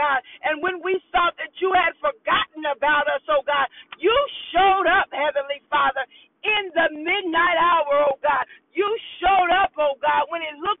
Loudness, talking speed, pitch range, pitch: -21 LUFS, 180 wpm, 290-370 Hz, 320 Hz